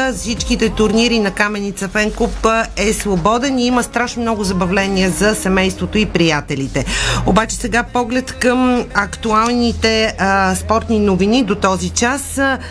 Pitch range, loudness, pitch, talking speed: 195-235 Hz, -15 LUFS, 220 Hz, 125 wpm